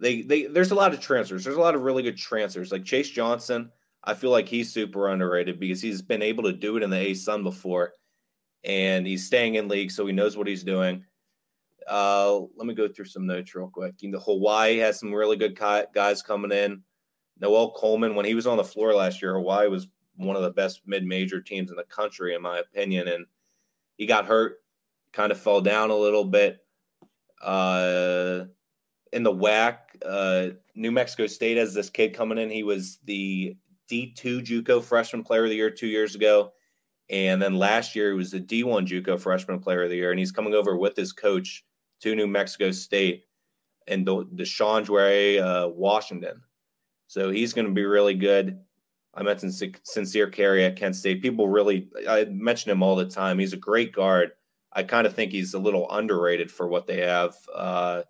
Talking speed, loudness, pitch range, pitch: 200 wpm, -25 LUFS, 95-110 Hz, 100 Hz